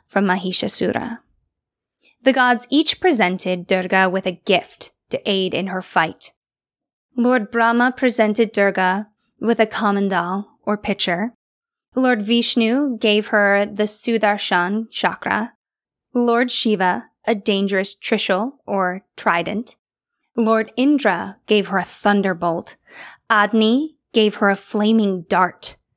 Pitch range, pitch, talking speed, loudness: 190-235 Hz, 210 Hz, 115 wpm, -19 LUFS